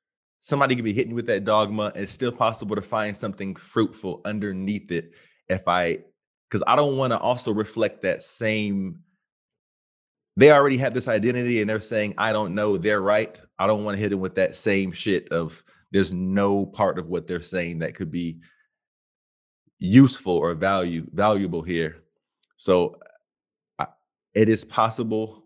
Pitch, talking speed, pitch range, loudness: 105 Hz, 165 wpm, 90-110 Hz, -23 LUFS